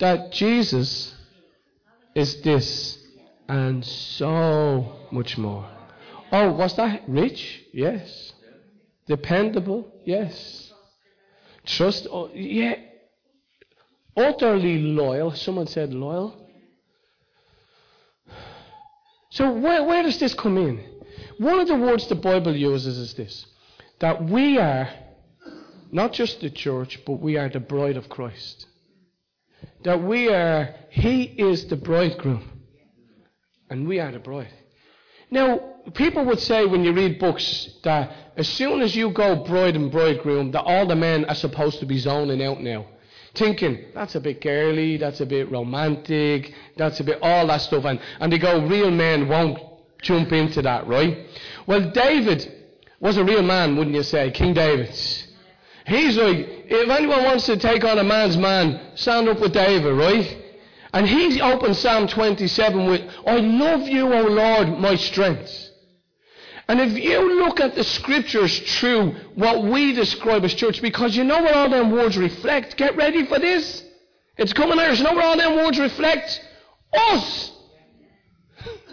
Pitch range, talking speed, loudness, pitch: 150-235 Hz, 150 wpm, -20 LUFS, 185 Hz